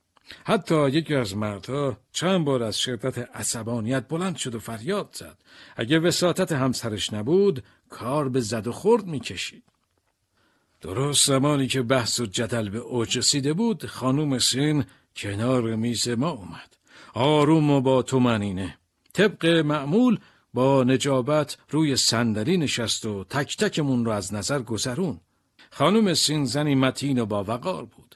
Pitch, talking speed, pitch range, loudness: 130 Hz, 140 wpm, 115-150 Hz, -24 LUFS